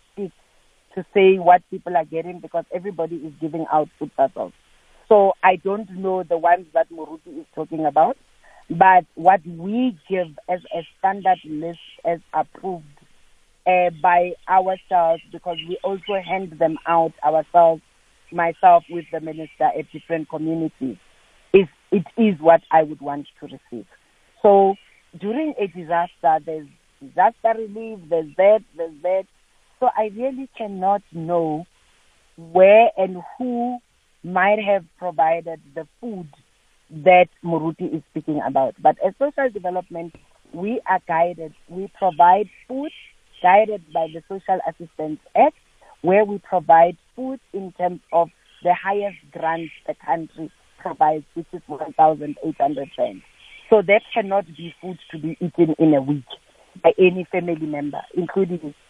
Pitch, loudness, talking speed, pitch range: 175 Hz, -20 LUFS, 140 wpm, 160-195 Hz